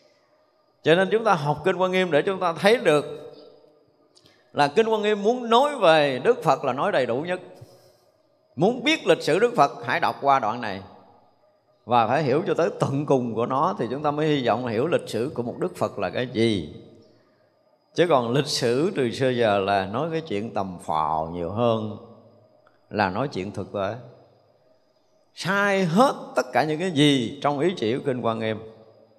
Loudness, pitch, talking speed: -23 LUFS, 145 Hz, 200 wpm